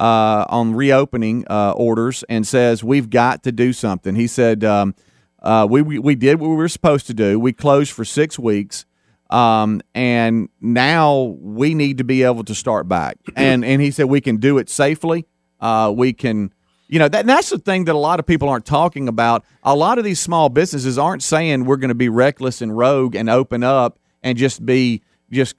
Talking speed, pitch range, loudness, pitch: 210 wpm, 115-145 Hz, -16 LUFS, 125 Hz